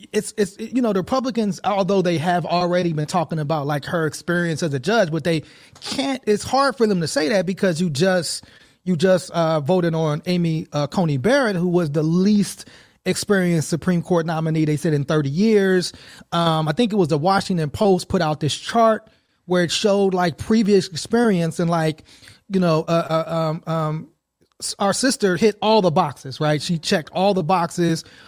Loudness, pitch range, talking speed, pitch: -20 LUFS, 160-200 Hz, 195 wpm, 180 Hz